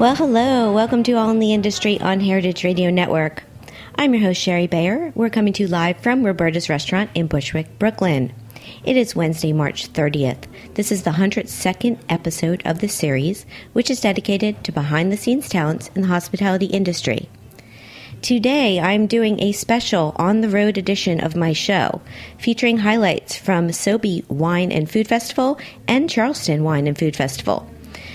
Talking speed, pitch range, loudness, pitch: 170 wpm, 160-220 Hz, -19 LUFS, 190 Hz